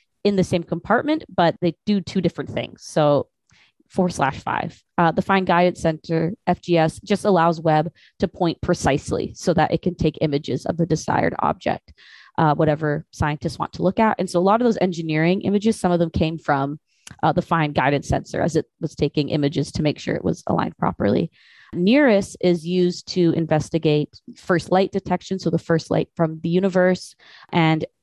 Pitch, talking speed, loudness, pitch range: 170 Hz, 190 wpm, -21 LUFS, 155-185 Hz